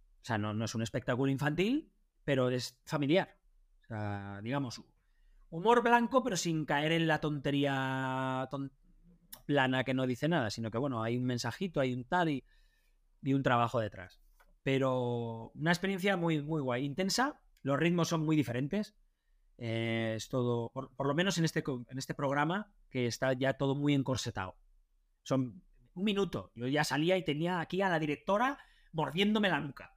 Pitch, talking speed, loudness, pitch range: 140 Hz, 175 wpm, -33 LUFS, 125-170 Hz